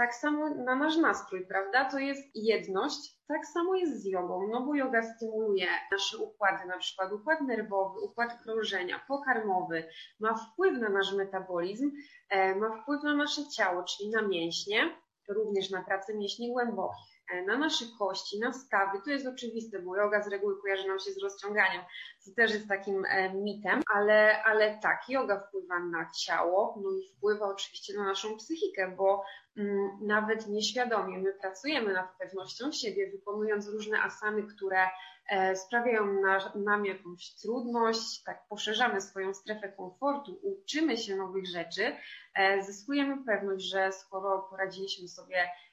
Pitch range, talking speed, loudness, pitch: 195-240 Hz, 155 wpm, -31 LUFS, 205 Hz